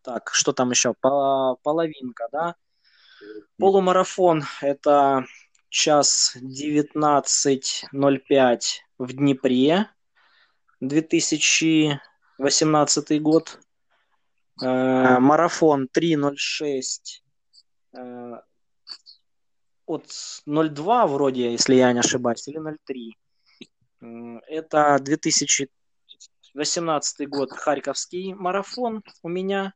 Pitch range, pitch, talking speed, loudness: 130-160 Hz, 145 Hz, 65 wpm, -21 LUFS